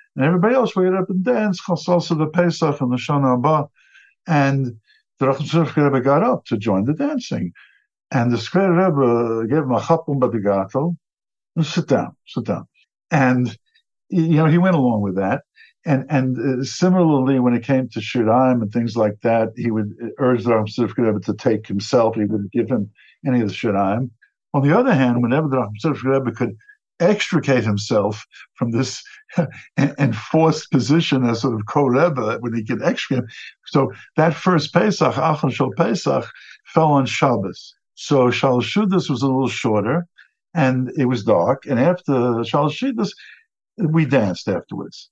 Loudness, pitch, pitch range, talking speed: -19 LUFS, 135 Hz, 120-165 Hz, 170 wpm